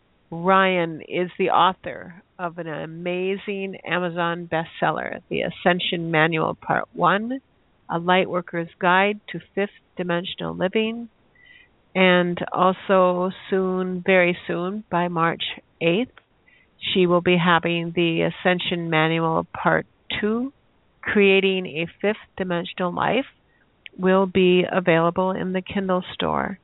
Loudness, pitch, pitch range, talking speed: -22 LUFS, 180 Hz, 170-190 Hz, 110 wpm